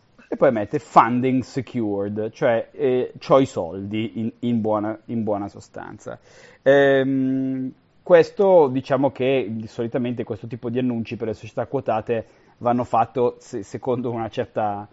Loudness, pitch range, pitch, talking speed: -22 LUFS, 110-130 Hz, 120 Hz, 135 wpm